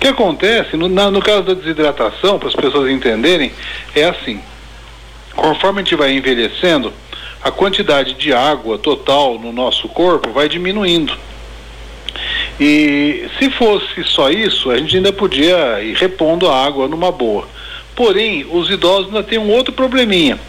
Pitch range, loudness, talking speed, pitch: 135-205 Hz, -13 LUFS, 155 wpm, 180 Hz